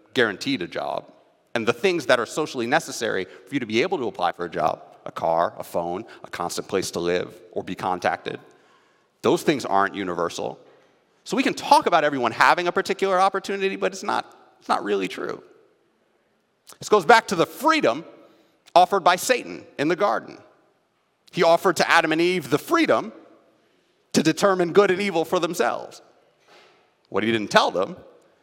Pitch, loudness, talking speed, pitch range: 180 Hz, -22 LUFS, 180 wpm, 155-200 Hz